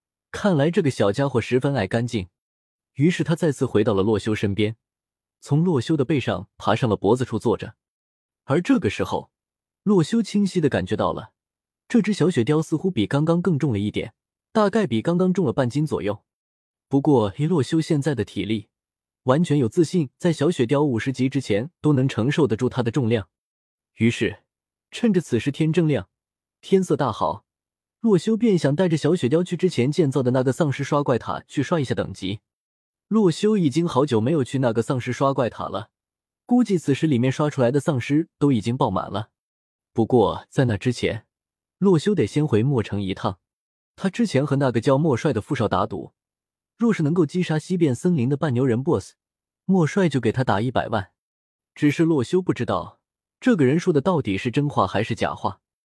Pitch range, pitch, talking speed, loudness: 115-165 Hz, 140 Hz, 285 characters per minute, -22 LUFS